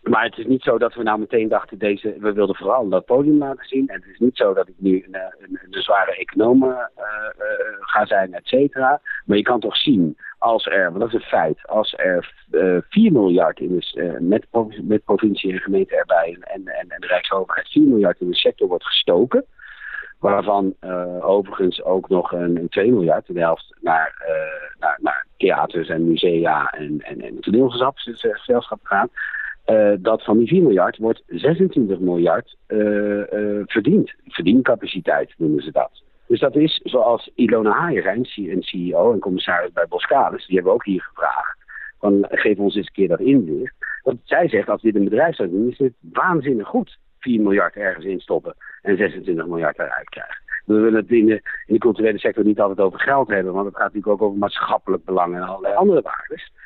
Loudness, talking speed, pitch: -19 LUFS, 205 wpm, 110 Hz